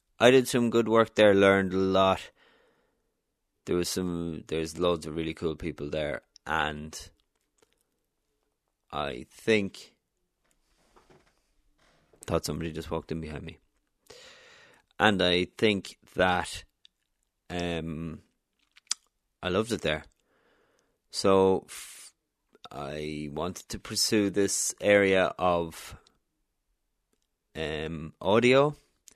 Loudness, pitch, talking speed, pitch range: -27 LUFS, 90 Hz, 100 wpm, 80-105 Hz